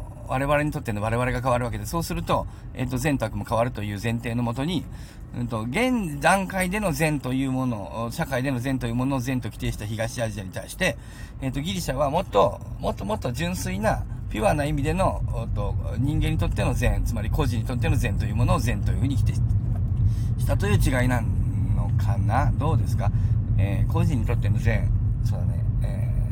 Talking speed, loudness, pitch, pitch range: 405 characters per minute, -25 LUFS, 115 Hz, 110-130 Hz